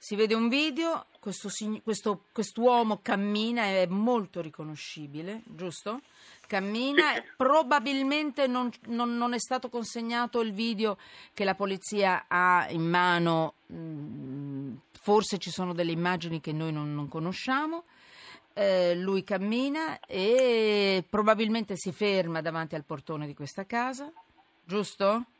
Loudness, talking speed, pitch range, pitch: -28 LUFS, 125 wpm, 175-240 Hz, 205 Hz